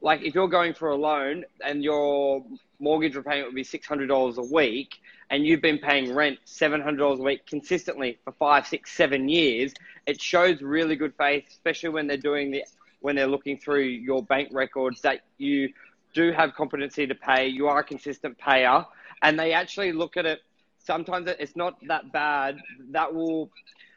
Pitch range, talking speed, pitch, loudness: 140-160 Hz, 205 wpm, 145 Hz, -25 LUFS